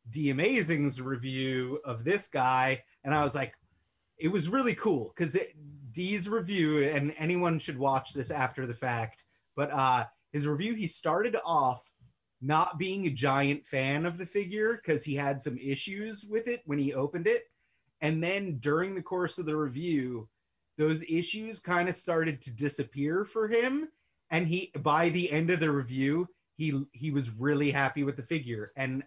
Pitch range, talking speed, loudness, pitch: 135-175 Hz, 180 wpm, -30 LUFS, 150 Hz